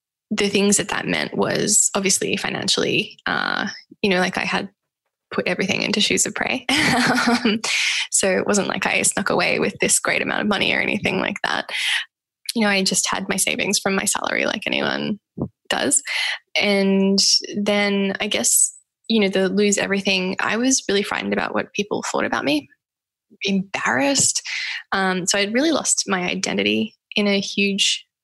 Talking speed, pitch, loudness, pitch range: 170 wpm, 200 Hz, -19 LUFS, 195-220 Hz